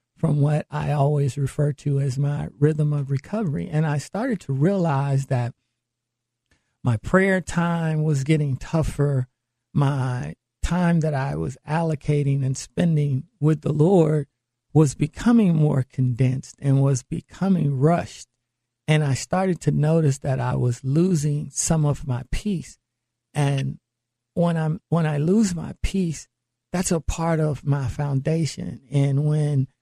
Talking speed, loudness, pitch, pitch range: 145 wpm, -23 LUFS, 145 Hz, 130-160 Hz